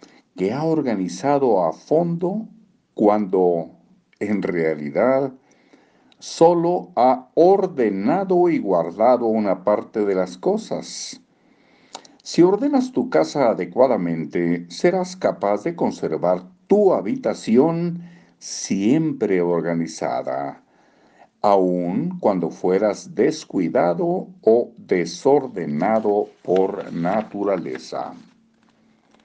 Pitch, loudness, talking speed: 125 Hz, -20 LUFS, 80 wpm